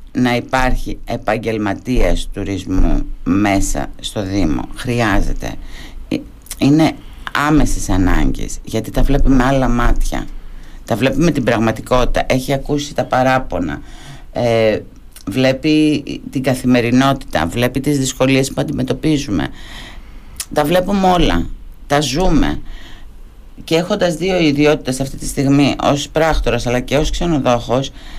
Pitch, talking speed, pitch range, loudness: 130 Hz, 110 wpm, 110-145 Hz, -16 LUFS